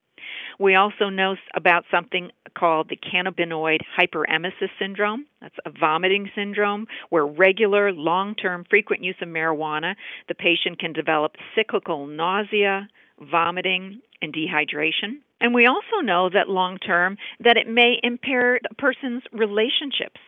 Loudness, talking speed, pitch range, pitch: -21 LUFS, 125 wpm, 170-215 Hz, 190 Hz